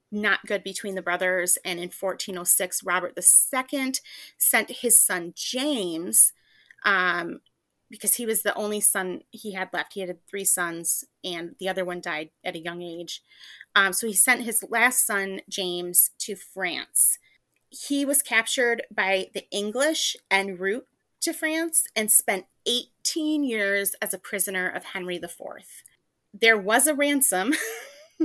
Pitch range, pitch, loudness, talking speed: 185-250 Hz, 200 Hz, -21 LUFS, 150 wpm